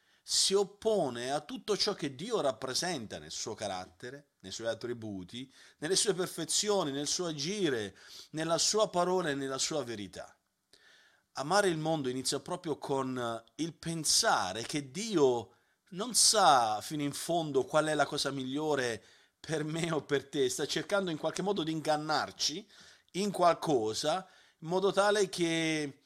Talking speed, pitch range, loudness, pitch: 150 wpm, 135-185 Hz, -31 LUFS, 155 Hz